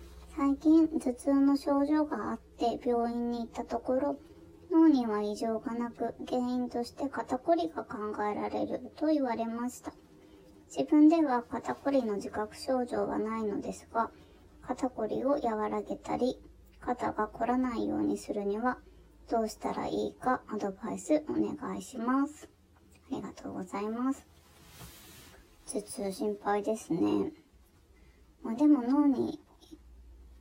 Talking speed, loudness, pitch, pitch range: 260 characters per minute, -31 LUFS, 240 Hz, 210-280 Hz